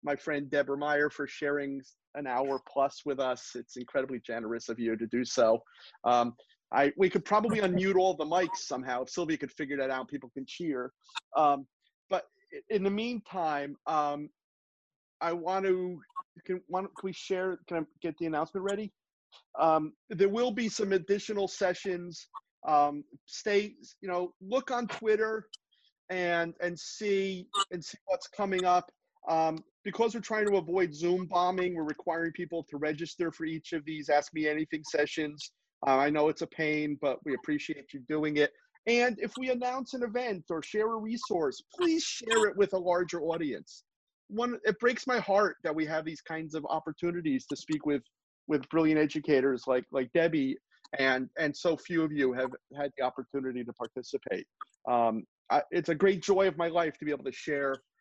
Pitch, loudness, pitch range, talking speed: 170 Hz, -31 LUFS, 145-205 Hz, 180 wpm